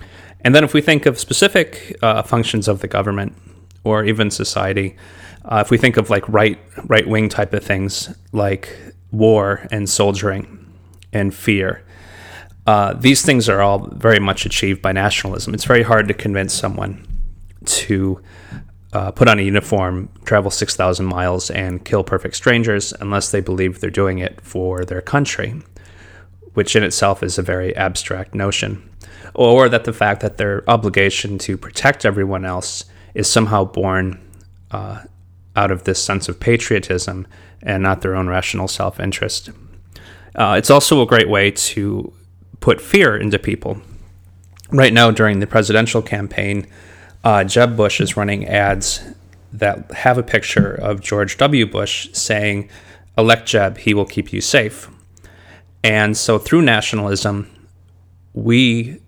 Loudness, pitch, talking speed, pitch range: -16 LUFS, 100 Hz, 155 wpm, 90-110 Hz